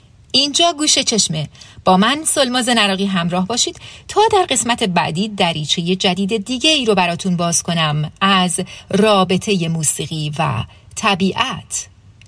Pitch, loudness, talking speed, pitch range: 190 Hz, -16 LUFS, 125 wpm, 160-230 Hz